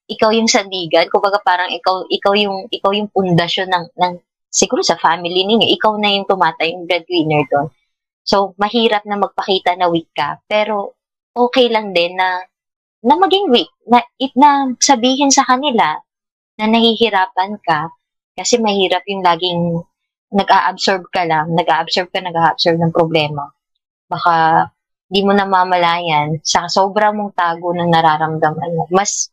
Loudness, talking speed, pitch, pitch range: -15 LUFS, 150 wpm, 185 Hz, 170-210 Hz